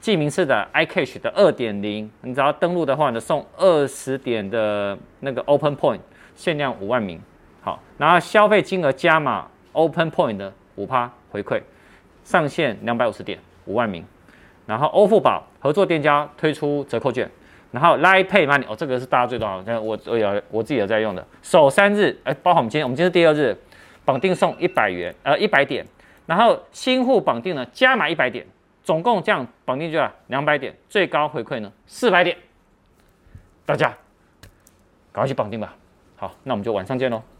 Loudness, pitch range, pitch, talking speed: -20 LUFS, 115-170 Hz, 140 Hz, 320 characters per minute